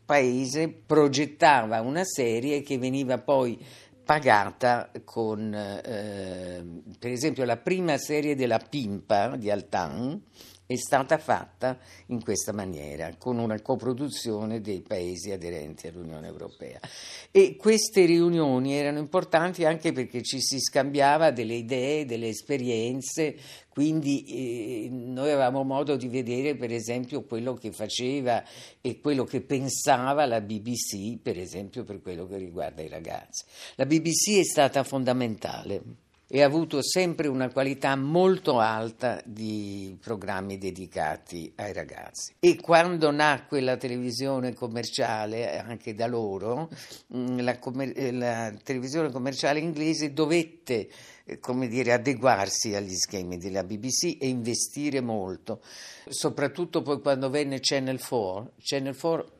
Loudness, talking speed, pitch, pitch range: -27 LUFS, 125 wpm, 130 Hz, 110-145 Hz